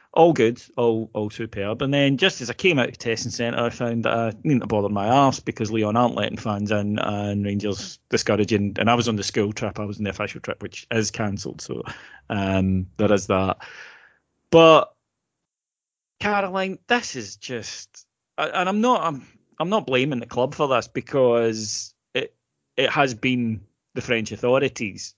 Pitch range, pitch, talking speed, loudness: 105-135 Hz, 115 Hz, 190 wpm, -22 LUFS